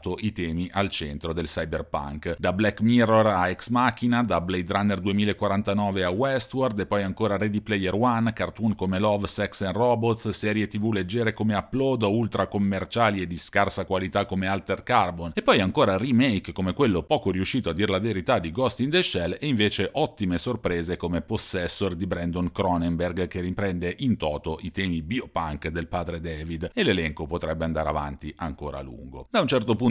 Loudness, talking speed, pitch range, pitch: -25 LUFS, 185 wpm, 85-110 Hz, 95 Hz